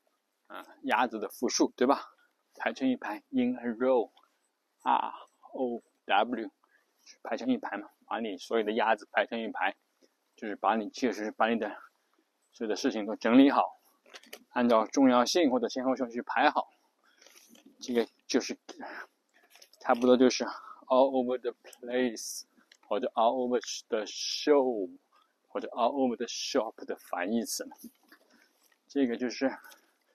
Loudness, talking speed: -30 LUFS, 260 characters per minute